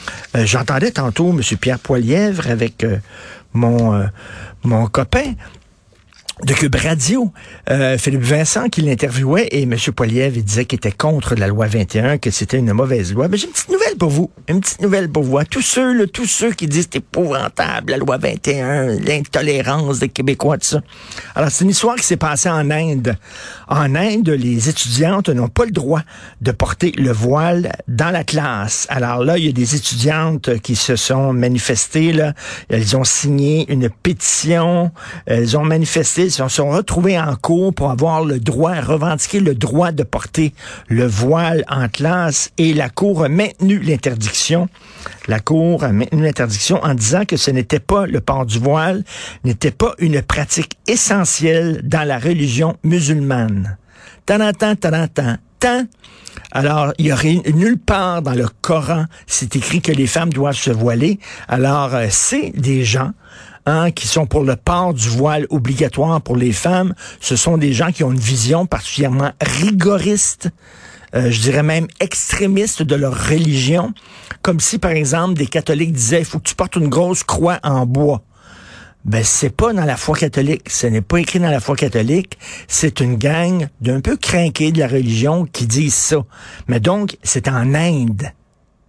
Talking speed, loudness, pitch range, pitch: 180 wpm, -16 LUFS, 125-170 Hz, 150 Hz